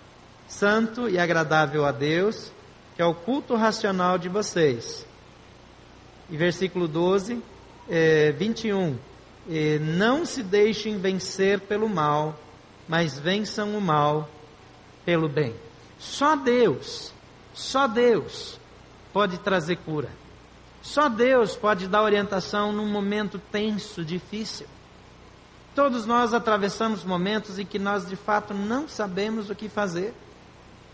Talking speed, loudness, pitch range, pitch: 115 wpm, -25 LUFS, 165-215 Hz, 200 Hz